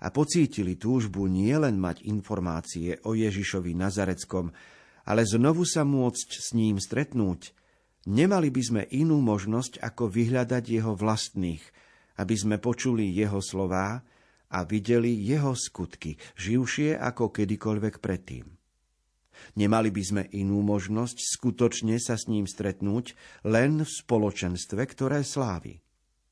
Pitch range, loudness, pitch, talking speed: 95-125 Hz, -27 LUFS, 110 Hz, 120 wpm